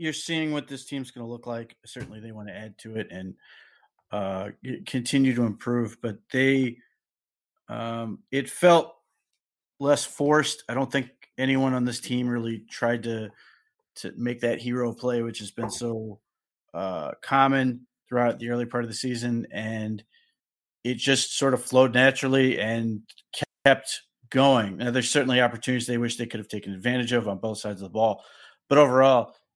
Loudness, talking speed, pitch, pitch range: -25 LUFS, 175 wpm, 120 Hz, 115-135 Hz